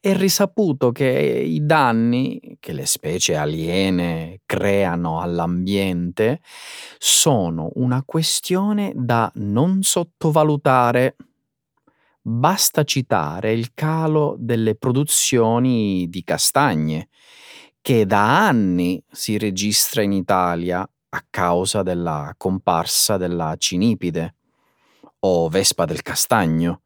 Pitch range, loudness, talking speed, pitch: 90-130 Hz, -19 LUFS, 95 wpm, 105 Hz